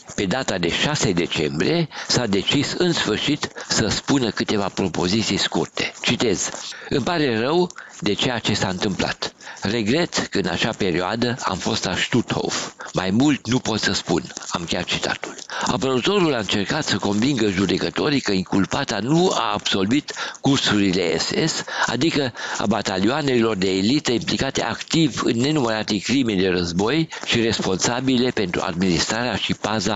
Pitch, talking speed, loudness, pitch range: 110 Hz, 145 wpm, -21 LUFS, 95-135 Hz